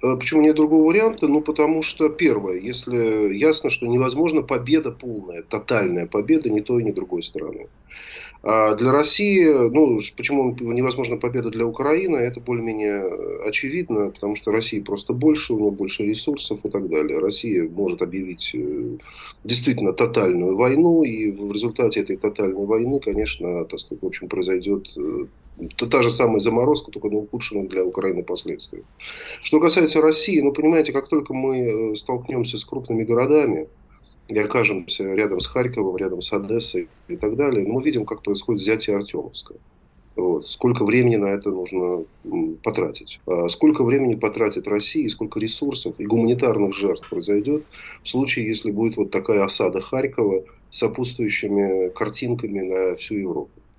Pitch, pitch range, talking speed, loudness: 120 Hz, 105-155 Hz, 150 wpm, -21 LUFS